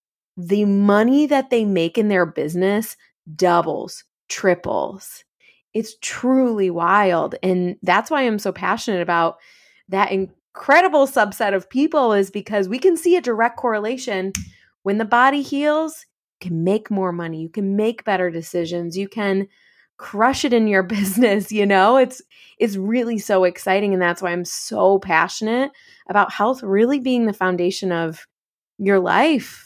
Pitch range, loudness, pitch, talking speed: 185-240 Hz, -19 LUFS, 205 Hz, 155 wpm